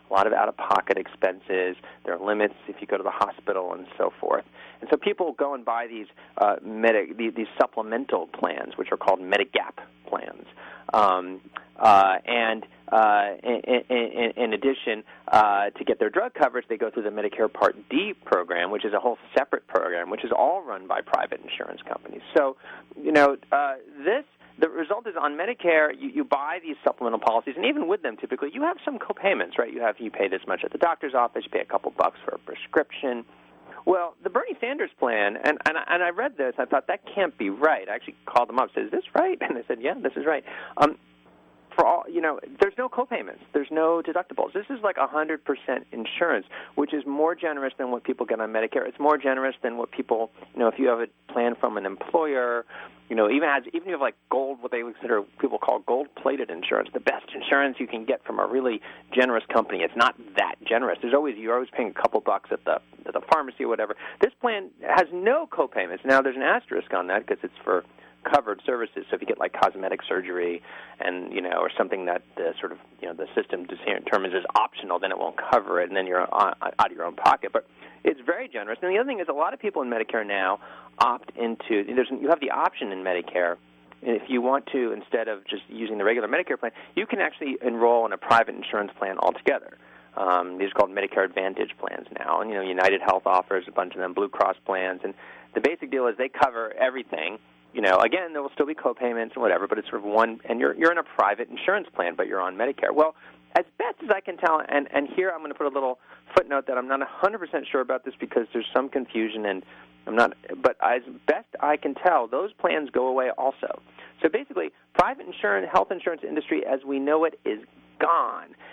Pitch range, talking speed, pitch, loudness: 110-155 Hz, 230 wpm, 130 Hz, -25 LUFS